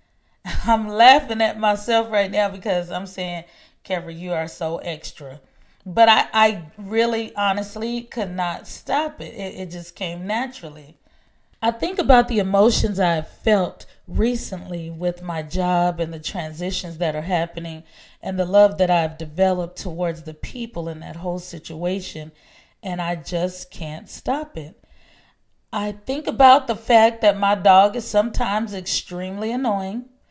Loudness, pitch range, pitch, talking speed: -21 LUFS, 170-220 Hz, 190 Hz, 150 wpm